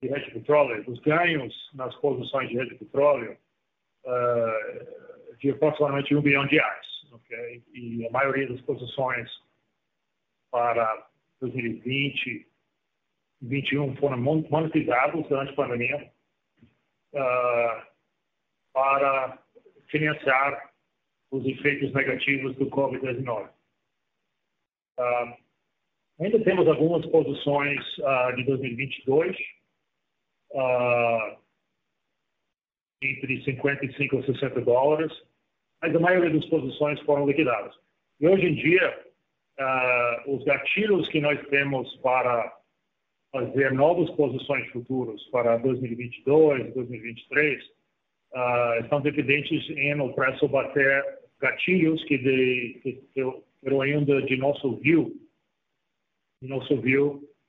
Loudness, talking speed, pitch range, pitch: -25 LUFS, 100 wpm, 125-150 Hz, 135 Hz